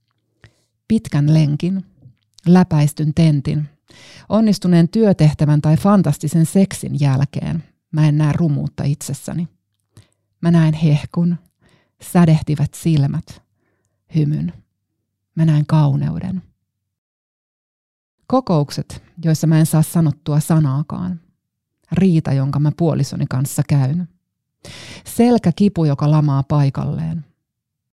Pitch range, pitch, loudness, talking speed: 140-170 Hz, 155 Hz, -17 LUFS, 90 wpm